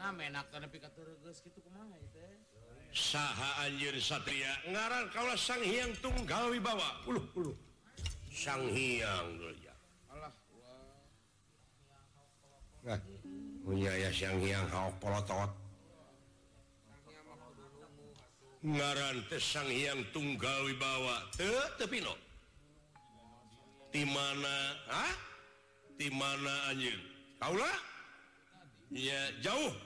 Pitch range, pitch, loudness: 110-145 Hz, 135 Hz, -37 LUFS